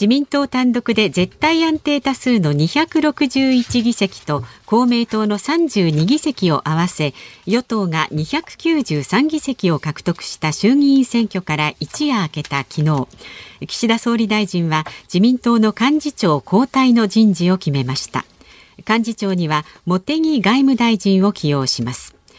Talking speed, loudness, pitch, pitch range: 245 characters per minute, -17 LUFS, 210 Hz, 155-255 Hz